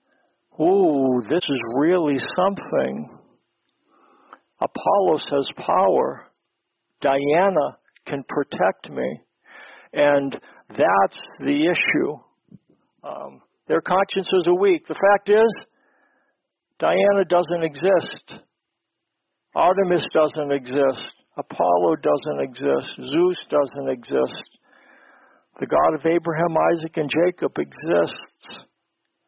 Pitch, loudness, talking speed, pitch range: 165 Hz, -21 LUFS, 90 wpm, 140-195 Hz